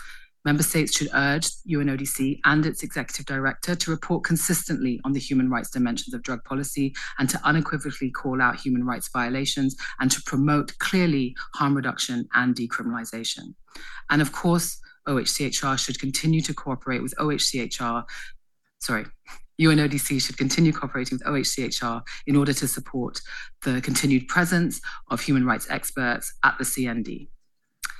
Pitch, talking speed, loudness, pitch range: 140 Hz, 145 wpm, -24 LUFS, 130-155 Hz